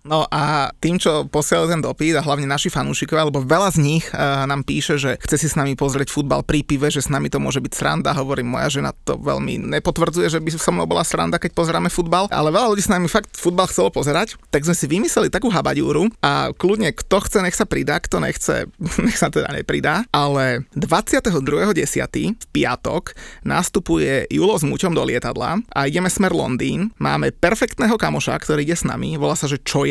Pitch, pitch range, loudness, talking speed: 155 Hz, 145-180 Hz, -19 LUFS, 205 wpm